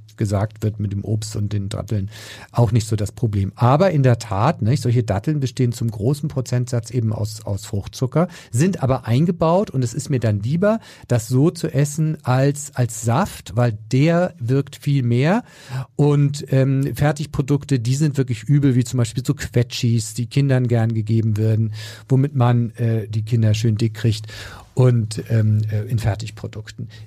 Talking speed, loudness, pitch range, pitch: 175 wpm, -20 LUFS, 110-140 Hz, 120 Hz